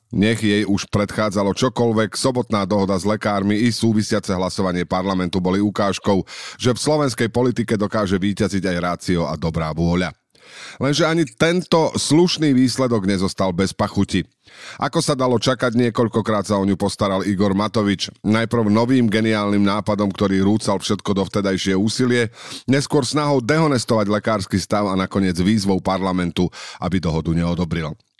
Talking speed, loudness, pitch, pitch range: 145 wpm, -19 LUFS, 105 Hz, 95-120 Hz